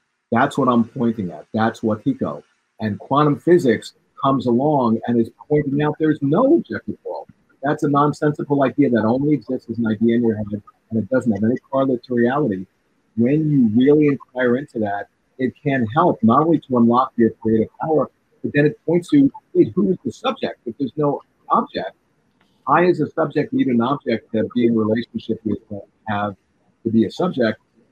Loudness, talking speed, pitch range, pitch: -19 LUFS, 195 wpm, 115-150 Hz, 125 Hz